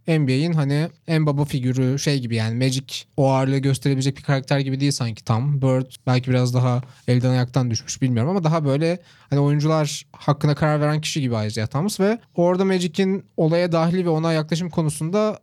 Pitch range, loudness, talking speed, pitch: 130-160 Hz, -21 LUFS, 185 wpm, 145 Hz